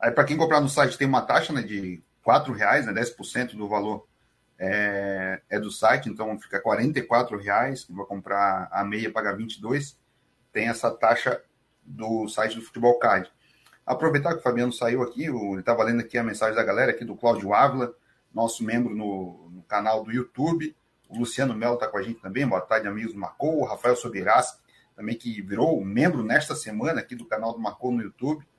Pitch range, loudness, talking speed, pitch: 105-125 Hz, -25 LUFS, 195 wpm, 115 Hz